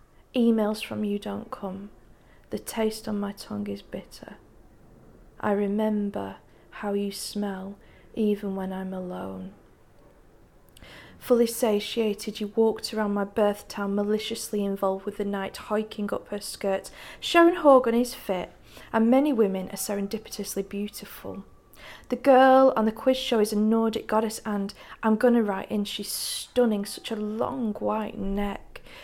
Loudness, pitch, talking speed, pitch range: -26 LUFS, 210 Hz, 145 wpm, 200-225 Hz